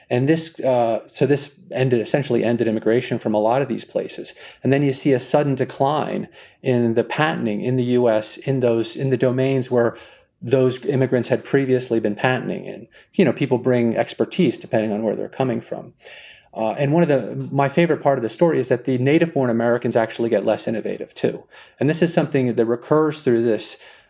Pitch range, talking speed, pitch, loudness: 115-140 Hz, 205 wpm, 130 Hz, -20 LUFS